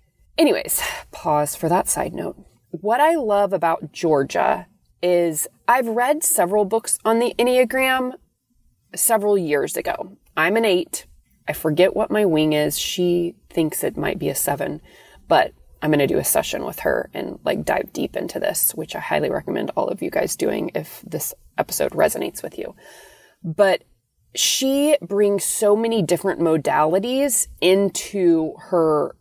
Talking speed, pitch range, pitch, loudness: 160 wpm, 165-230 Hz, 195 Hz, -20 LUFS